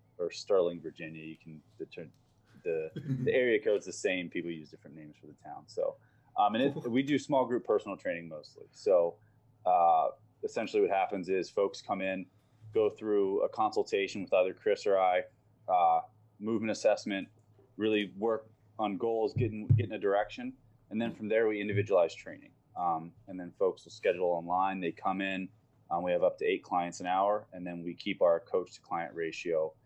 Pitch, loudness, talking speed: 120 Hz, -32 LUFS, 190 wpm